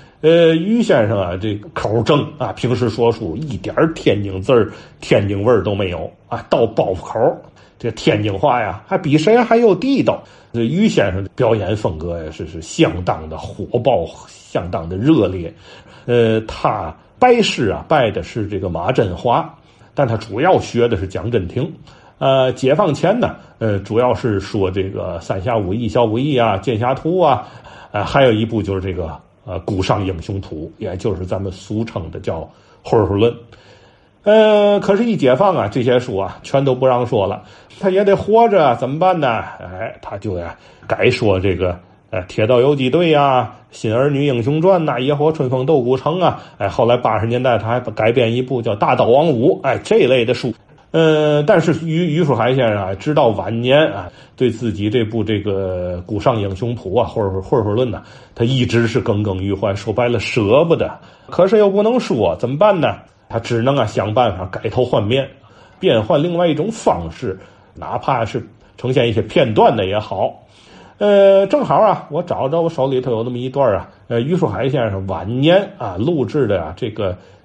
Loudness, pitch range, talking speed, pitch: -16 LUFS, 100-145 Hz, 265 characters per minute, 120 Hz